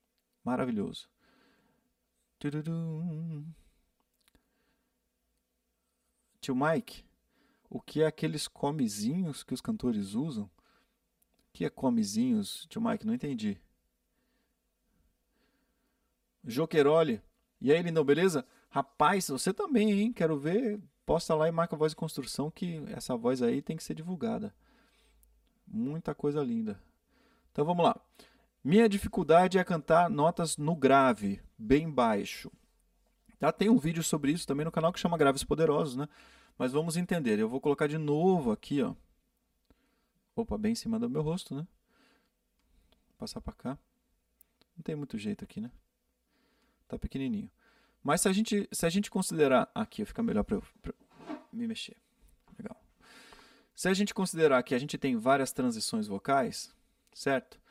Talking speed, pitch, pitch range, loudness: 140 wpm, 195 Hz, 155-225 Hz, -31 LUFS